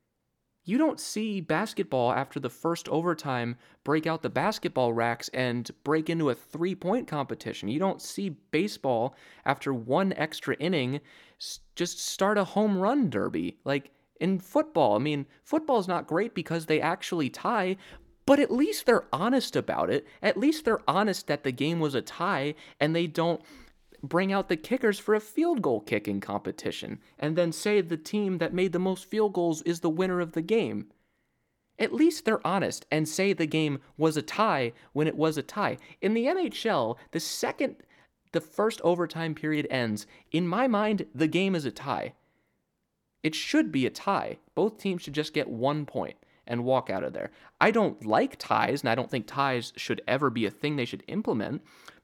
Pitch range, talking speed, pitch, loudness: 140-195 Hz, 185 wpm, 165 Hz, -28 LUFS